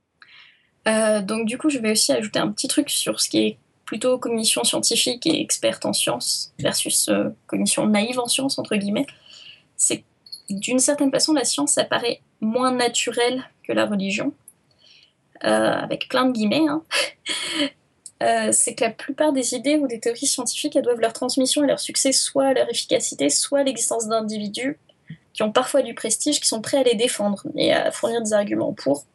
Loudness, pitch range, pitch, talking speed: -21 LUFS, 220-285 Hz, 250 Hz, 185 wpm